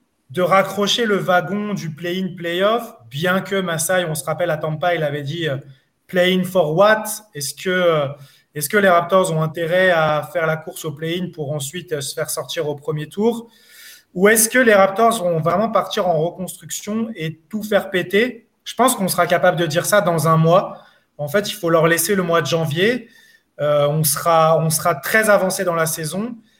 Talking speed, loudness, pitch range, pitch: 200 wpm, -18 LUFS, 160-205 Hz, 175 Hz